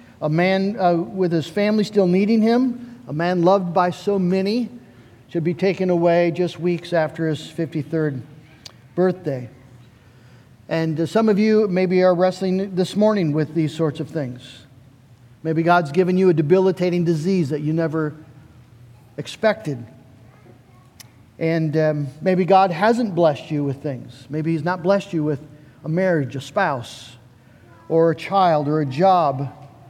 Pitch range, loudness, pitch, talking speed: 135-185 Hz, -20 LUFS, 160 Hz, 155 wpm